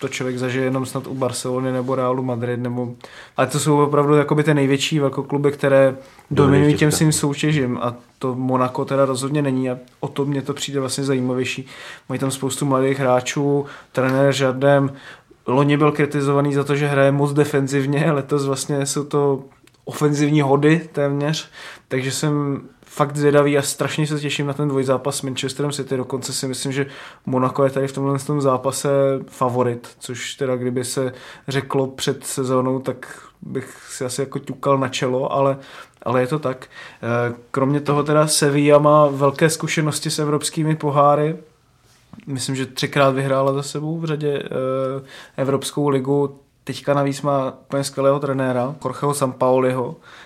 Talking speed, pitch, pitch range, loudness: 160 wpm, 140 Hz, 130-145 Hz, -20 LUFS